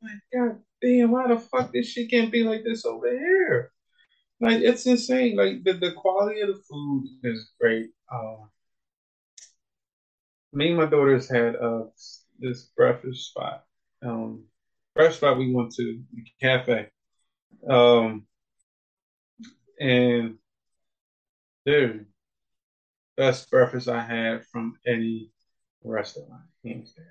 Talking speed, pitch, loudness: 120 wpm, 130 Hz, -24 LUFS